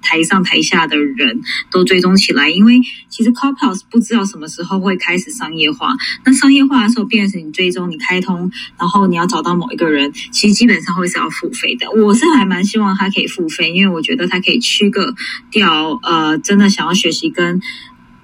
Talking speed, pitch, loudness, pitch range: 335 characters per minute, 190 Hz, -13 LUFS, 170-220 Hz